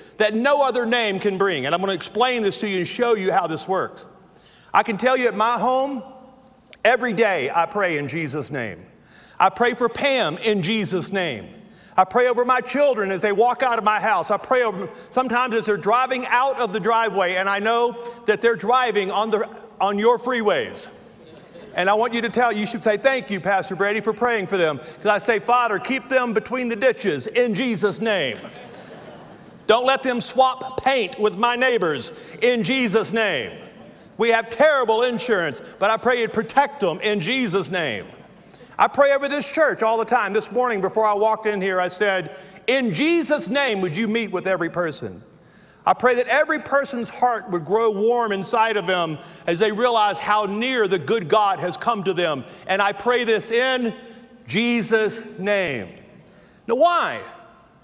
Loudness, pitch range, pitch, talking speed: -21 LUFS, 200-245 Hz, 225 Hz, 195 wpm